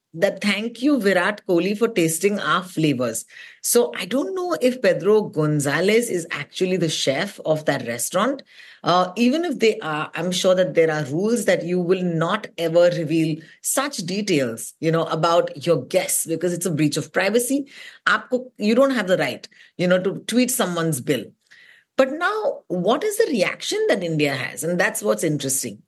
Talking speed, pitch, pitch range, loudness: 180 wpm, 180 Hz, 160-220 Hz, -21 LUFS